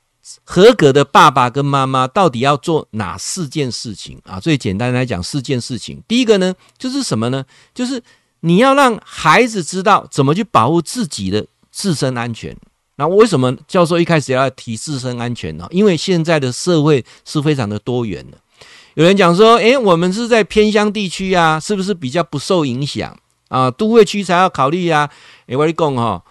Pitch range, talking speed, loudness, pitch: 125-185 Hz, 285 characters per minute, -14 LUFS, 150 Hz